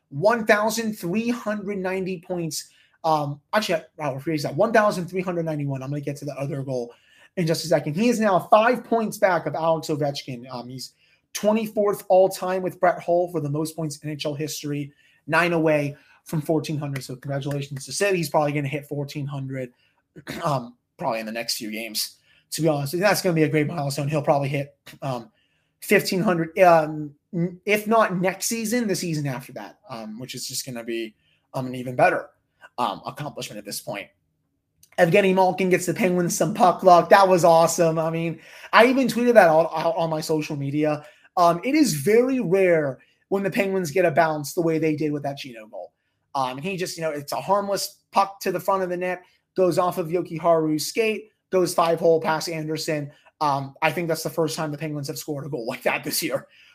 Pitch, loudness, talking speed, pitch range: 160 Hz, -23 LUFS, 205 wpm, 145-185 Hz